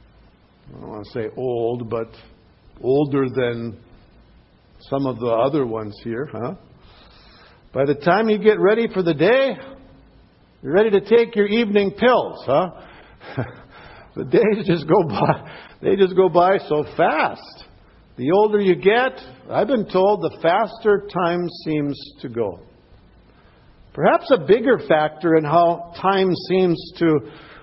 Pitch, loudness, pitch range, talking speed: 170 Hz, -19 LUFS, 135-200 Hz, 145 wpm